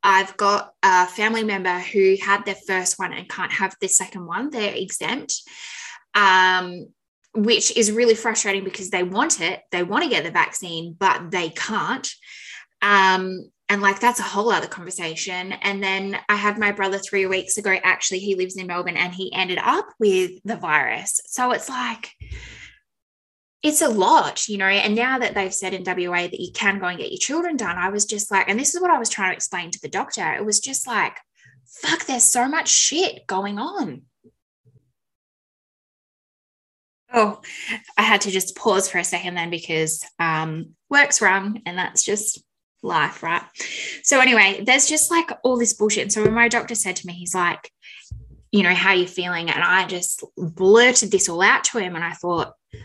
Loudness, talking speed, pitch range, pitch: -20 LUFS, 195 wpm, 180-230 Hz, 195 Hz